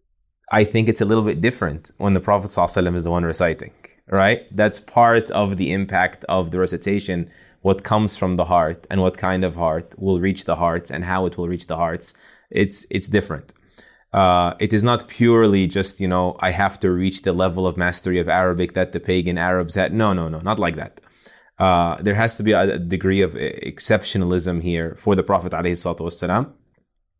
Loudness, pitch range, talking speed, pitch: -19 LUFS, 90-100 Hz, 200 wpm, 95 Hz